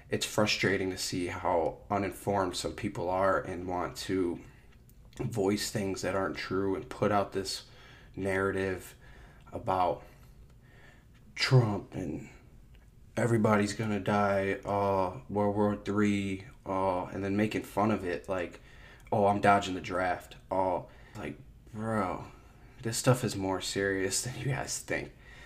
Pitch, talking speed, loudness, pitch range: 100 Hz, 135 wpm, -31 LUFS, 95-115 Hz